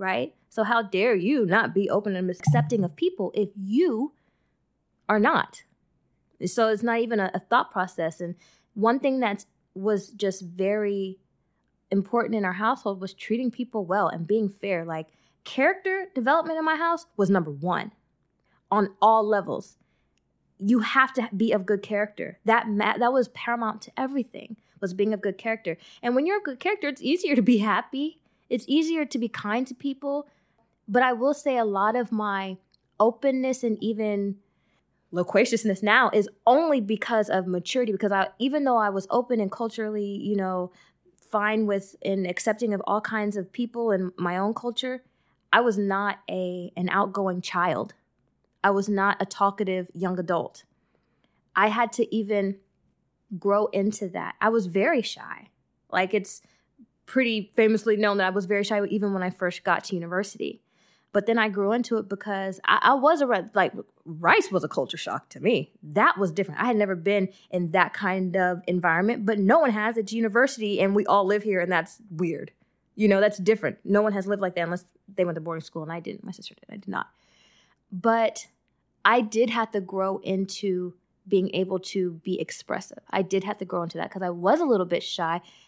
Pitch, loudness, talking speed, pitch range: 205 Hz, -25 LUFS, 190 wpm, 190-230 Hz